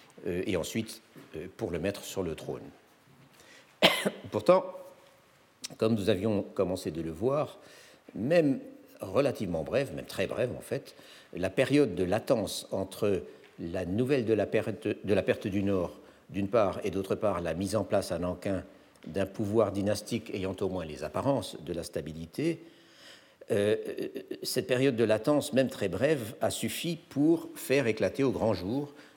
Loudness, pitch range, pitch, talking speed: -30 LUFS, 95-145 Hz, 110 Hz, 160 wpm